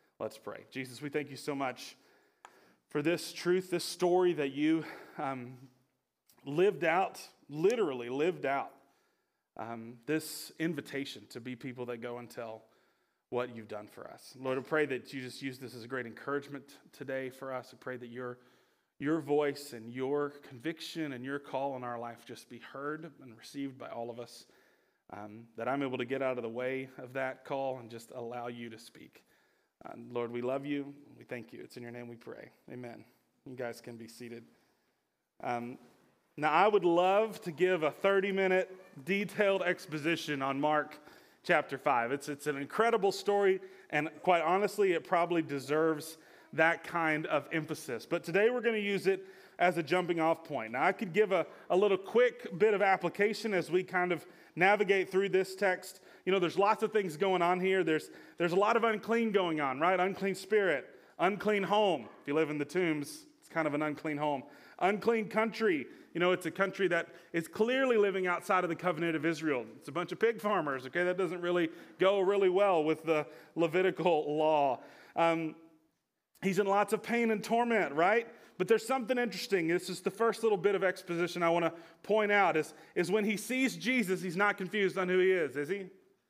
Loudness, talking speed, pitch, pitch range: -32 LUFS, 200 wpm, 165 Hz, 135-195 Hz